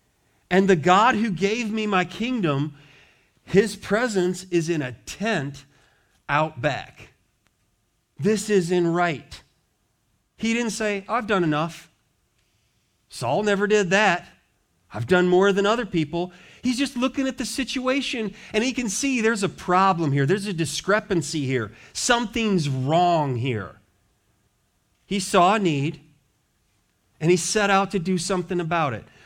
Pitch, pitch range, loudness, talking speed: 175 Hz, 130-210 Hz, -23 LUFS, 145 wpm